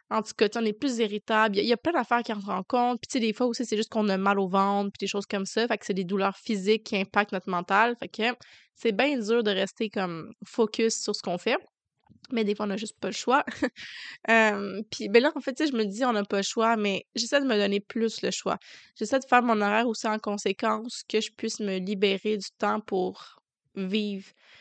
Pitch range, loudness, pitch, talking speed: 200-235 Hz, -27 LUFS, 215 Hz, 260 wpm